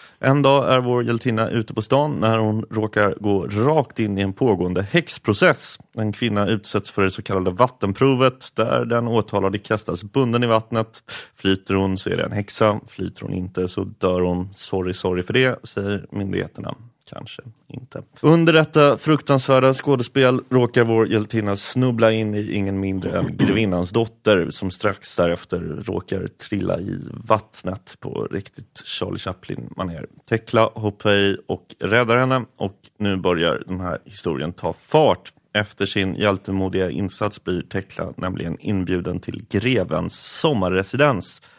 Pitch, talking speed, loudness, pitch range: 110 Hz, 150 wpm, -21 LUFS, 95-125 Hz